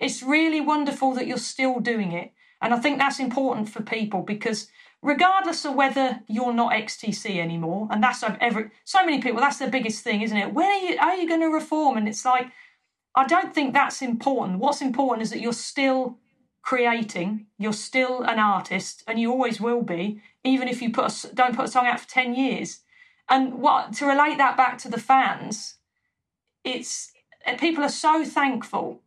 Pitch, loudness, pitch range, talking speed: 255 Hz, -23 LUFS, 225-280 Hz, 195 wpm